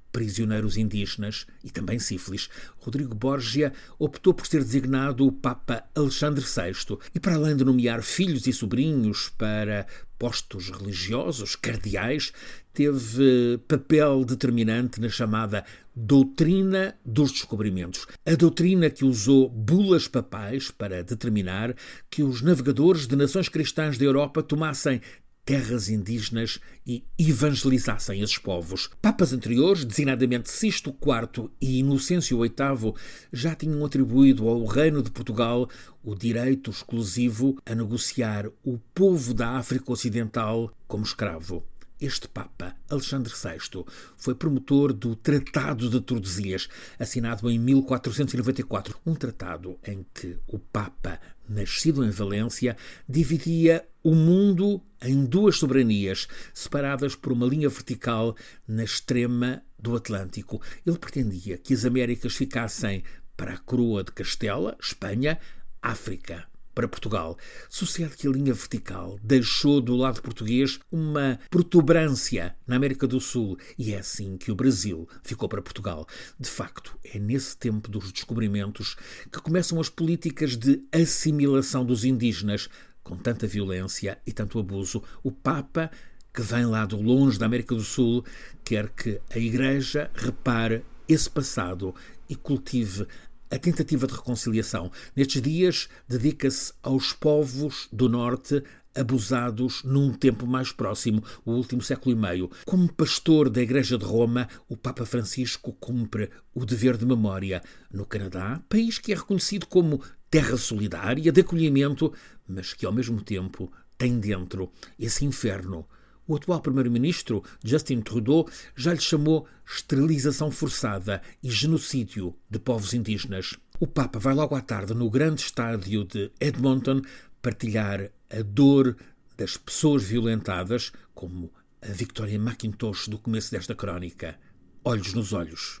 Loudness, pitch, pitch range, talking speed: -26 LUFS, 125 Hz, 110-140 Hz, 135 wpm